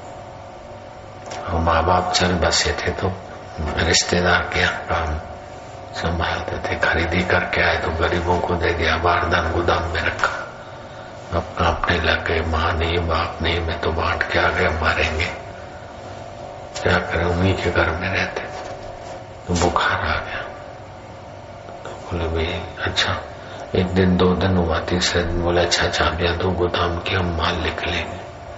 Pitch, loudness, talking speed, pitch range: 85 Hz, -20 LUFS, 150 wpm, 85-90 Hz